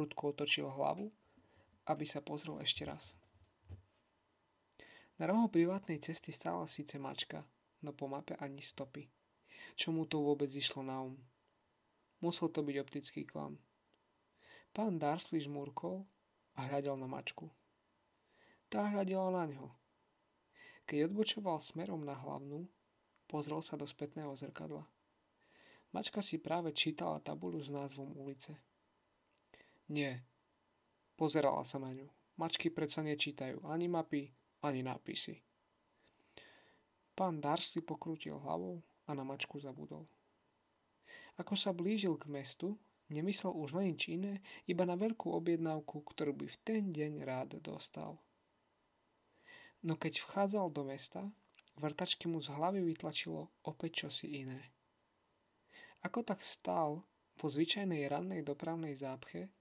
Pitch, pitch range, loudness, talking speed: 150 Hz, 140-170 Hz, -41 LUFS, 125 wpm